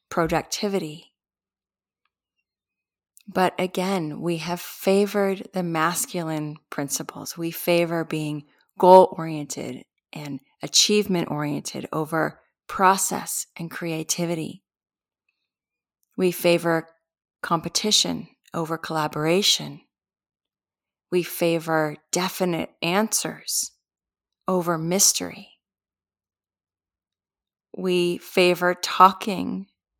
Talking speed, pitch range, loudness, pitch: 70 wpm, 150-185 Hz, -23 LUFS, 165 Hz